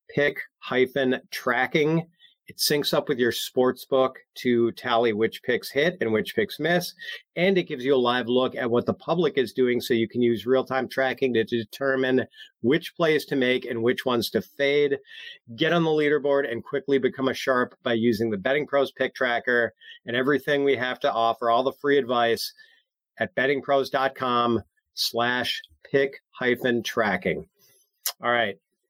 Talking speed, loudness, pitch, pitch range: 170 wpm, -24 LUFS, 130 Hz, 120-145 Hz